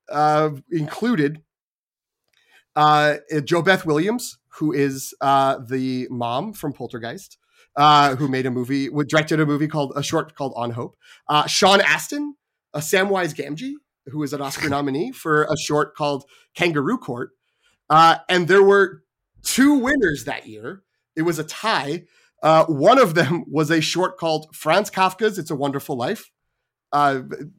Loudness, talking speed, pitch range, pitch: -20 LUFS, 155 wpm, 140-185 Hz, 150 Hz